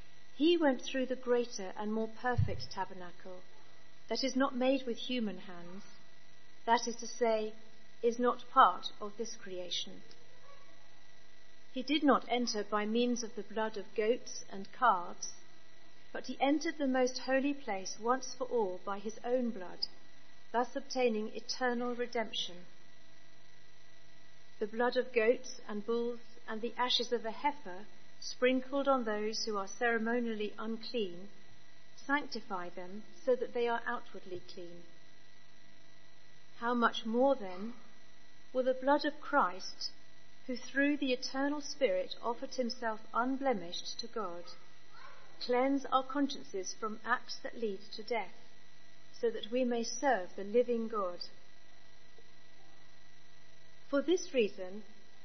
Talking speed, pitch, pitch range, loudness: 135 wpm, 230 Hz, 195-255 Hz, -35 LUFS